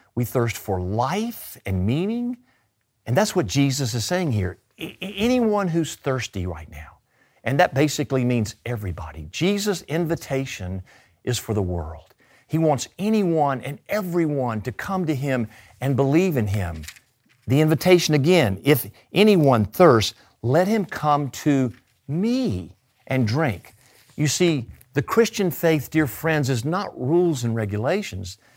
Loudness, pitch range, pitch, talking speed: -22 LUFS, 110-170 Hz, 135 Hz, 145 wpm